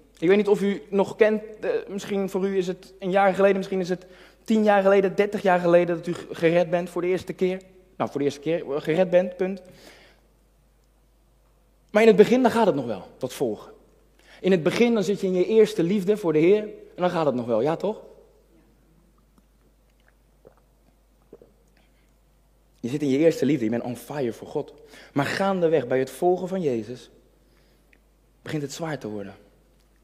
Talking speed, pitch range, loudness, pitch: 190 wpm, 165-200 Hz, -23 LUFS, 185 Hz